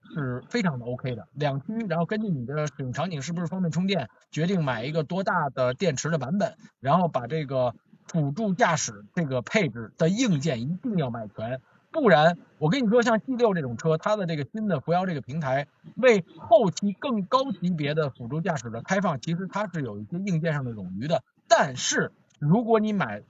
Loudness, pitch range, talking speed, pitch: -26 LUFS, 140-200 Hz, 305 characters per minute, 165 Hz